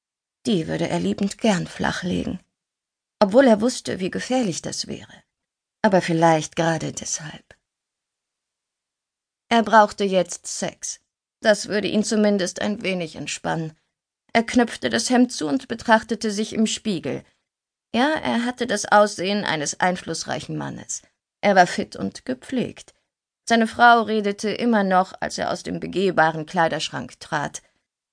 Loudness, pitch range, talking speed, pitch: -22 LUFS, 180-230 Hz, 135 wpm, 210 Hz